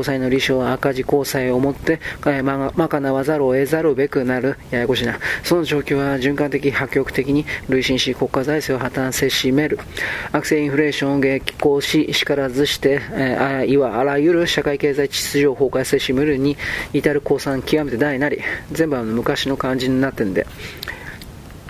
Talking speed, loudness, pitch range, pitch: 335 characters per minute, -19 LUFS, 130-145 Hz, 140 Hz